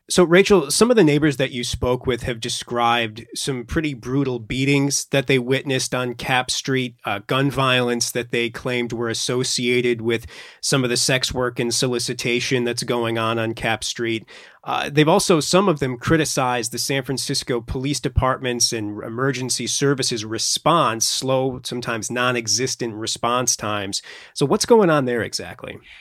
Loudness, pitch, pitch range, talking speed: -20 LUFS, 125 Hz, 120-140 Hz, 165 wpm